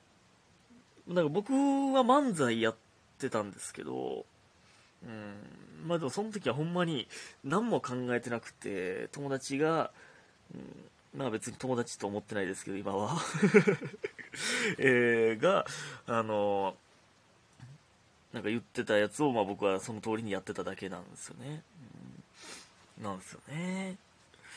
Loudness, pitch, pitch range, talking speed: -32 LUFS, 125 Hz, 105-170 Hz, 255 characters per minute